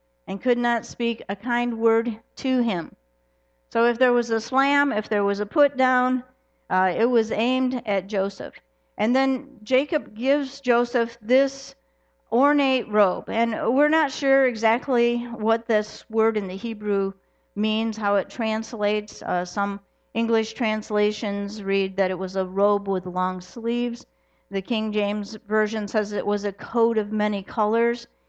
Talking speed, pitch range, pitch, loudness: 160 wpm, 205-240 Hz, 225 Hz, -23 LUFS